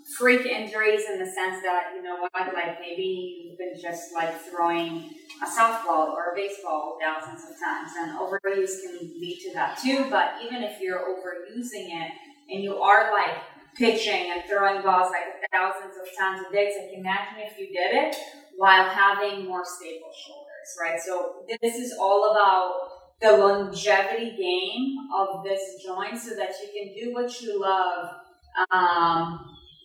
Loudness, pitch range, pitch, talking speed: -25 LUFS, 180-215 Hz, 190 Hz, 170 wpm